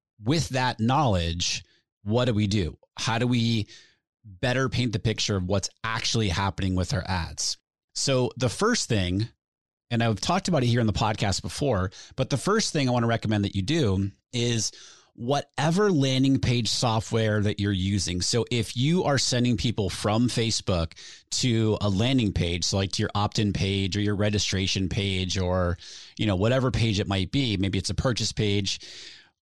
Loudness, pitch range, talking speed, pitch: -25 LUFS, 100-125 Hz, 180 wpm, 110 Hz